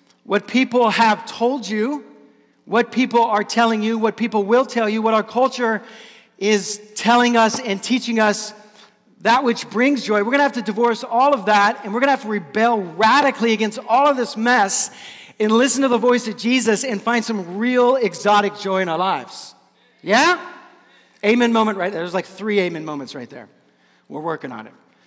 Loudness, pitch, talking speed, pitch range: -18 LUFS, 225 Hz, 195 wpm, 210-245 Hz